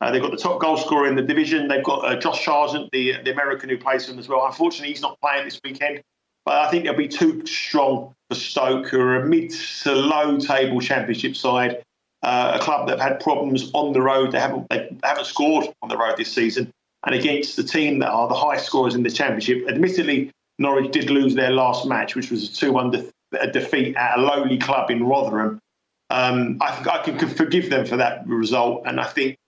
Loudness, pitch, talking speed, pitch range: -21 LUFS, 135 Hz, 230 wpm, 125-145 Hz